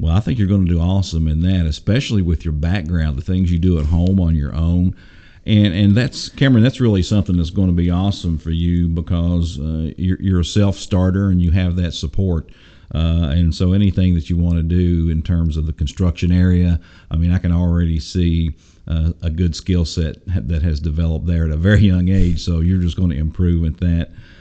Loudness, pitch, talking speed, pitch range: -17 LUFS, 85 Hz, 225 wpm, 80-95 Hz